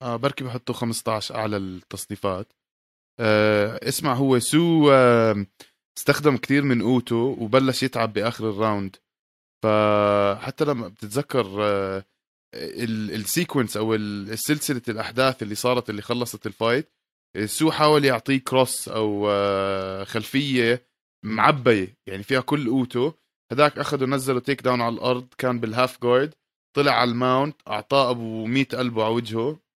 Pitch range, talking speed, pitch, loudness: 105-135 Hz, 125 wpm, 120 Hz, -22 LUFS